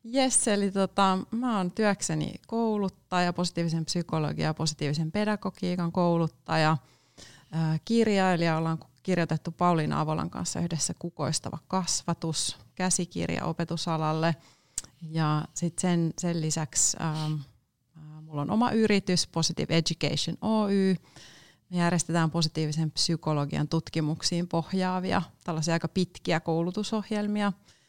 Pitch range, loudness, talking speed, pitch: 155-185 Hz, -28 LUFS, 100 wpm, 165 Hz